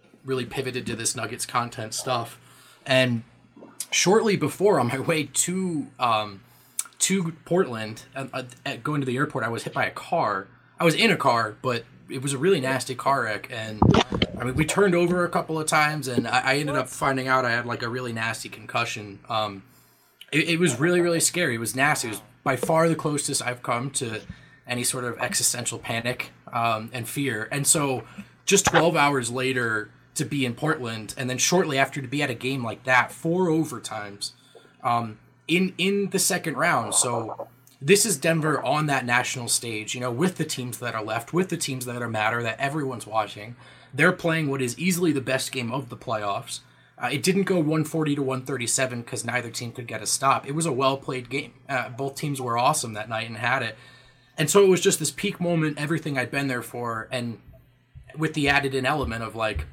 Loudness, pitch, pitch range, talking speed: -24 LUFS, 130 Hz, 120-155 Hz, 215 wpm